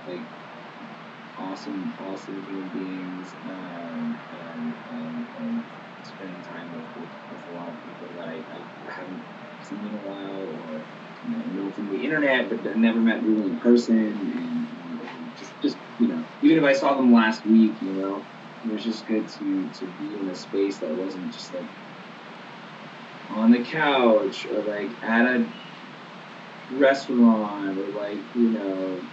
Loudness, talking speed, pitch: -25 LUFS, 165 wpm, 115 Hz